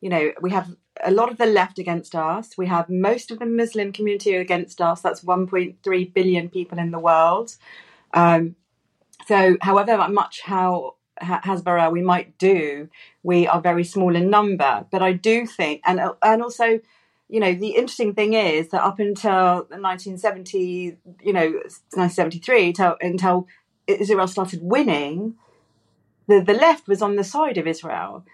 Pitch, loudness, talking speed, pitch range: 185 Hz, -20 LUFS, 165 wpm, 175-205 Hz